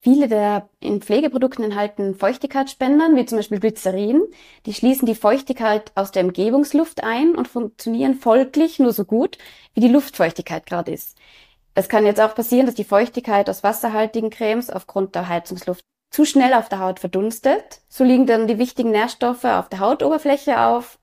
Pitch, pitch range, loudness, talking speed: 225 Hz, 205-260 Hz, -19 LUFS, 170 wpm